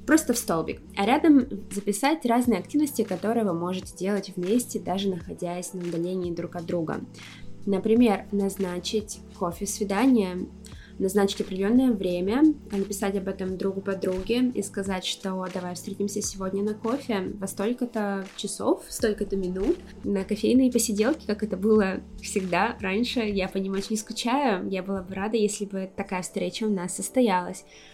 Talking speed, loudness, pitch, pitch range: 150 wpm, -26 LUFS, 200 Hz, 190-225 Hz